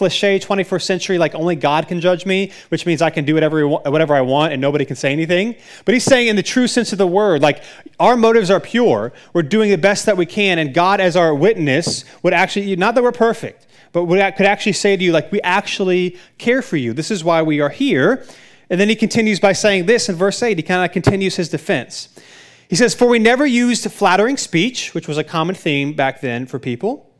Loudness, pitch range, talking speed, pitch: -16 LUFS, 160-210 Hz, 240 wpm, 185 Hz